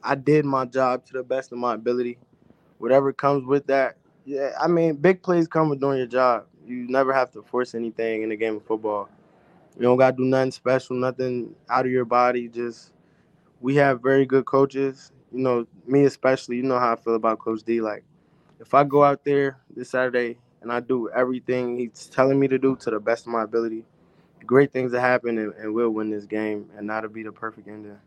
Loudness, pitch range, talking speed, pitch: -23 LUFS, 115-135 Hz, 220 wpm, 125 Hz